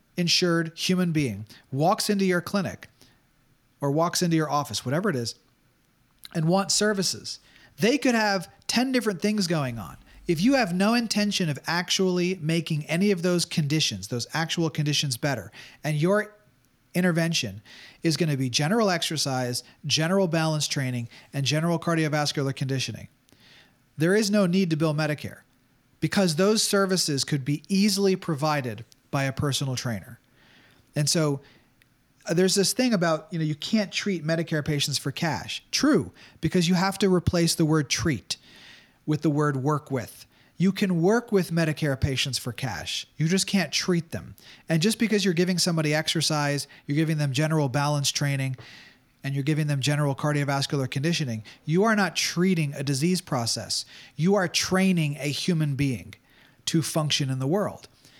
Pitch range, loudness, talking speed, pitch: 135-180 Hz, -25 LUFS, 160 wpm, 155 Hz